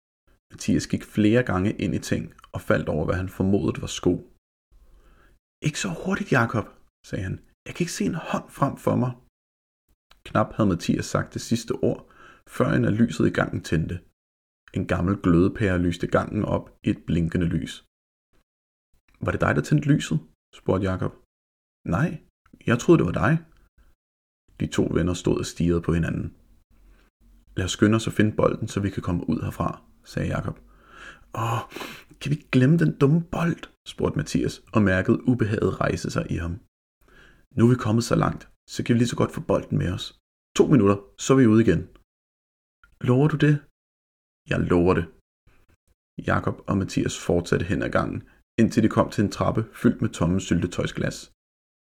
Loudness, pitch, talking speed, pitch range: -24 LUFS, 95 Hz, 180 wpm, 80-120 Hz